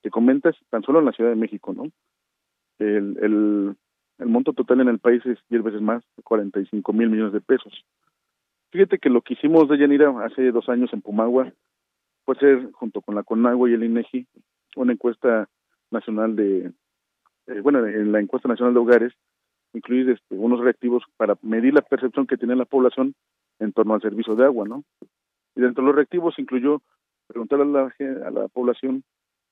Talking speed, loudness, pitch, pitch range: 185 wpm, -21 LUFS, 120 Hz, 110-130 Hz